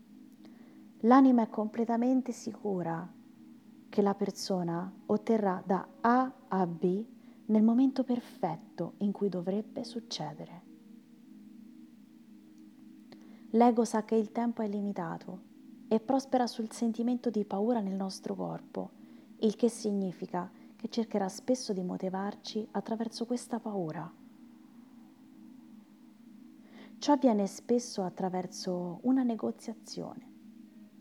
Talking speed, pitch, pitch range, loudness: 100 wpm, 230 Hz, 205-250 Hz, -32 LUFS